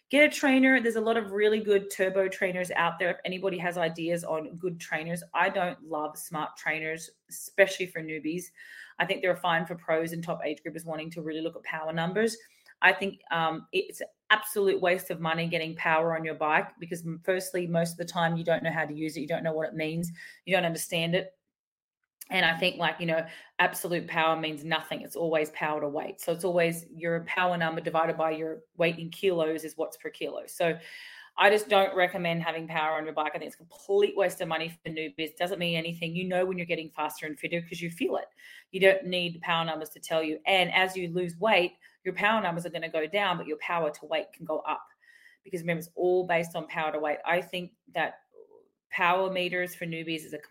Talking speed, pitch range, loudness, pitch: 235 wpm, 160-185 Hz, -29 LUFS, 170 Hz